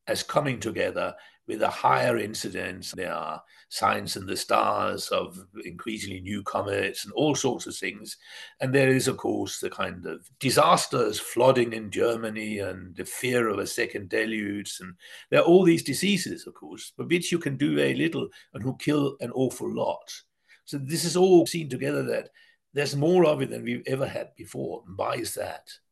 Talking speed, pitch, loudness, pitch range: 190 wpm, 130 Hz, -26 LUFS, 110-165 Hz